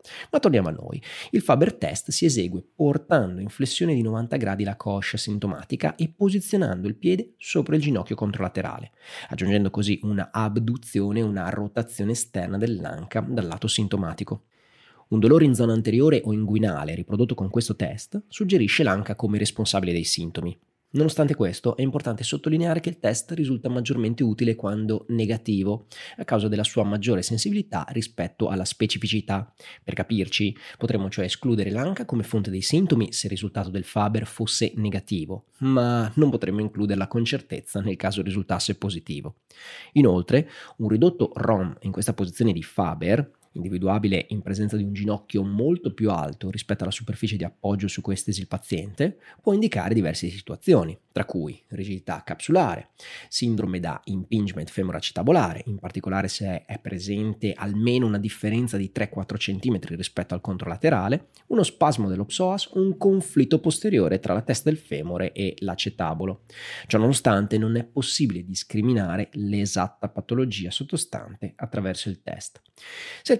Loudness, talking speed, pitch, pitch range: -25 LUFS, 150 wpm, 105 Hz, 95-120 Hz